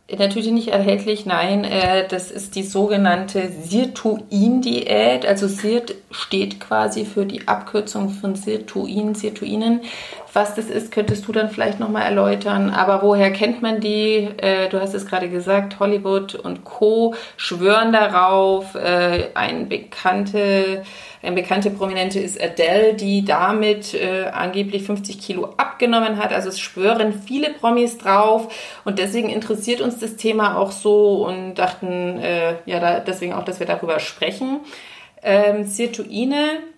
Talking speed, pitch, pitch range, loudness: 130 wpm, 205 Hz, 190-215 Hz, -19 LUFS